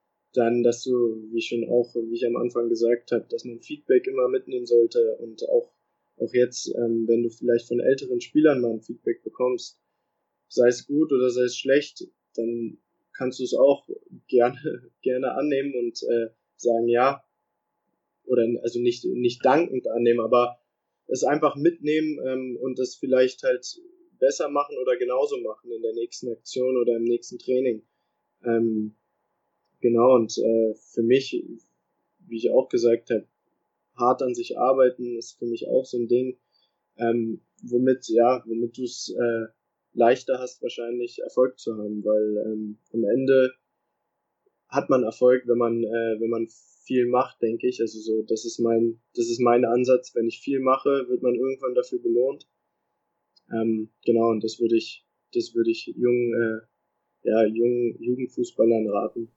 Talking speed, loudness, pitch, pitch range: 165 wpm, -24 LUFS, 120 Hz, 115-130 Hz